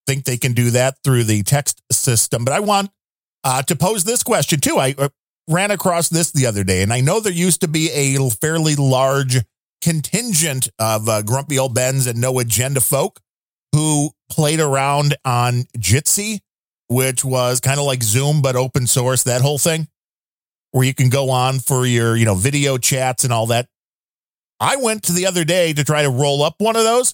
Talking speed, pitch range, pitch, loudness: 200 wpm, 125-160 Hz, 135 Hz, -17 LUFS